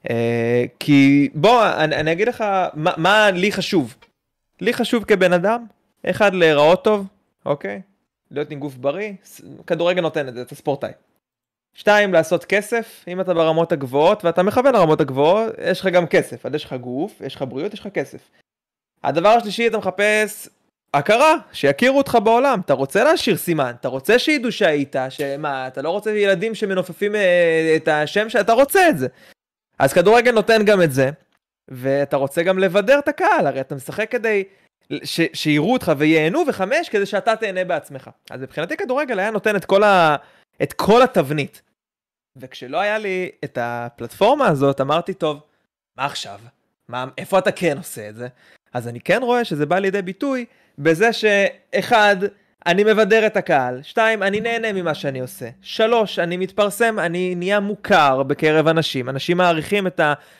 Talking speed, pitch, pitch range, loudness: 165 wpm, 180 Hz, 145-215 Hz, -18 LUFS